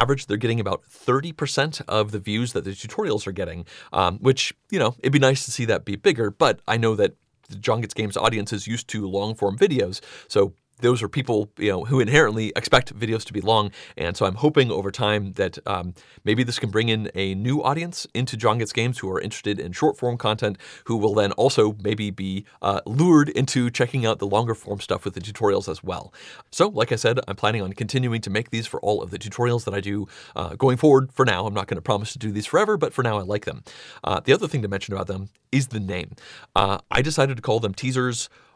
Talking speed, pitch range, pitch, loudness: 240 wpm, 105-130 Hz, 110 Hz, -23 LUFS